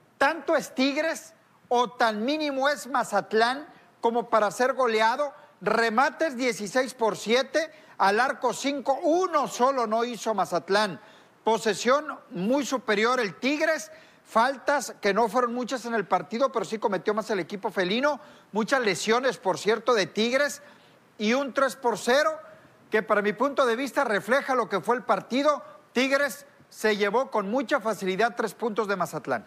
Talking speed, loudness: 155 wpm, -26 LUFS